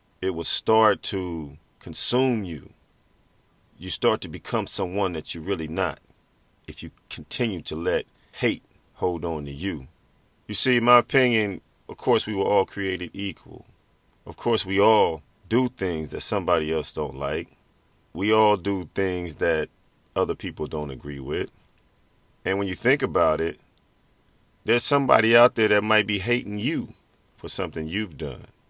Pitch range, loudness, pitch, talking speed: 80-110 Hz, -24 LUFS, 95 Hz, 160 wpm